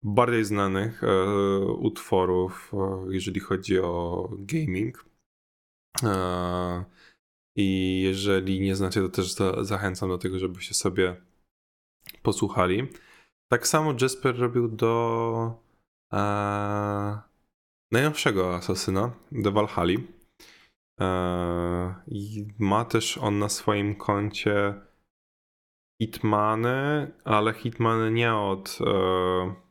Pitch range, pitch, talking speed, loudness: 95-110 Hz, 100 Hz, 95 wpm, -26 LUFS